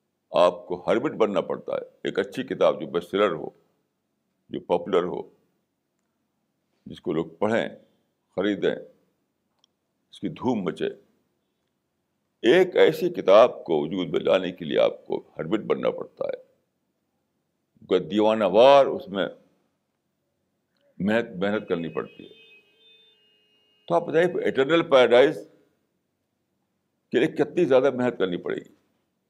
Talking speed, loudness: 125 wpm, -23 LUFS